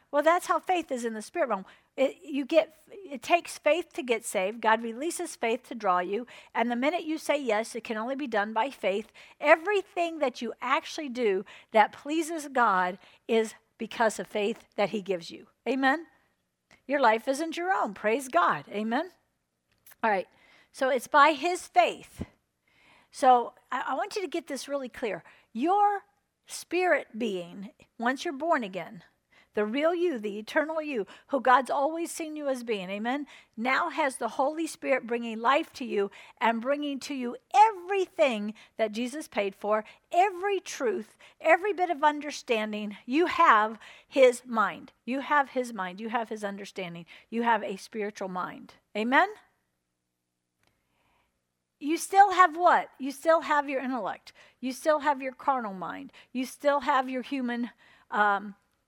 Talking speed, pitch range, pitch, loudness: 165 wpm, 220-315 Hz, 260 Hz, -28 LUFS